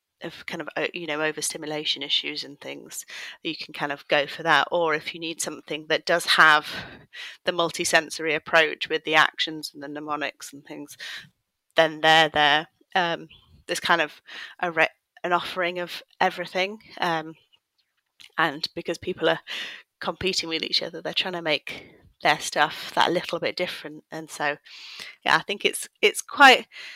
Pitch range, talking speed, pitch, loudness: 155-175 Hz, 165 wpm, 160 Hz, -23 LUFS